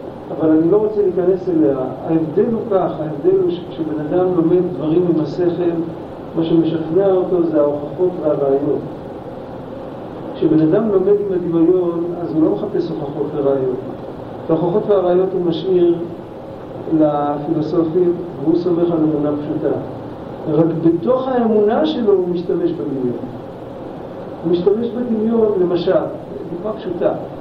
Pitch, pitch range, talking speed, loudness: 175 Hz, 160-185 Hz, 125 wpm, -17 LUFS